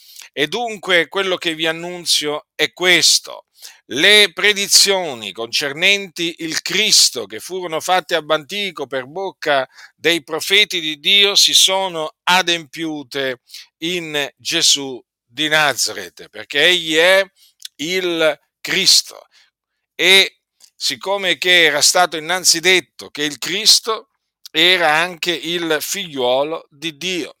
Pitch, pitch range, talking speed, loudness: 170 Hz, 150-185 Hz, 115 wpm, -15 LUFS